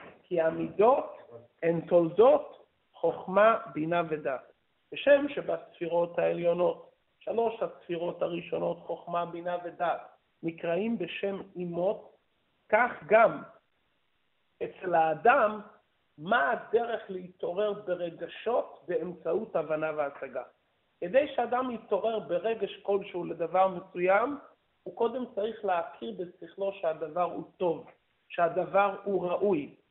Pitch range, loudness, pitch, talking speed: 170-210 Hz, -29 LUFS, 180 Hz, 95 wpm